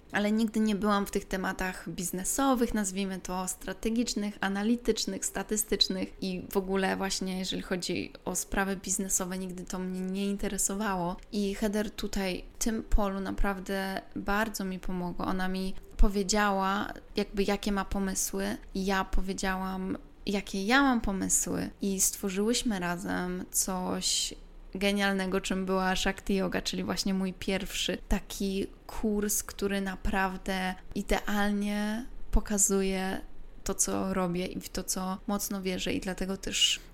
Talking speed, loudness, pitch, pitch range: 130 wpm, -31 LUFS, 195 Hz, 190-205 Hz